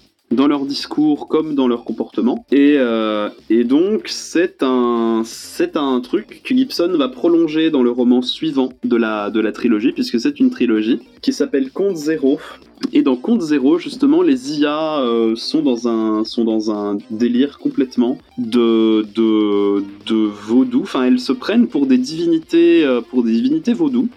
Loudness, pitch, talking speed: -17 LUFS, 135 Hz, 170 wpm